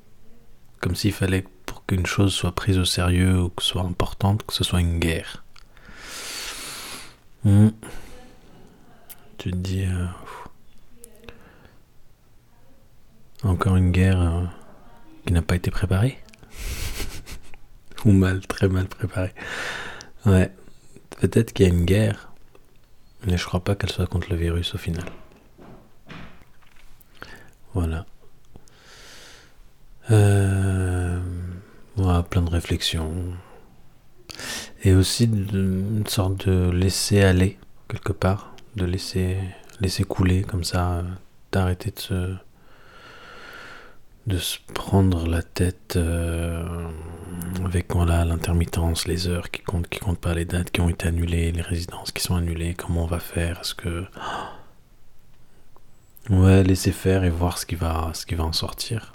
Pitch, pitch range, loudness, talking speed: 95 Hz, 85-100 Hz, -23 LUFS, 130 wpm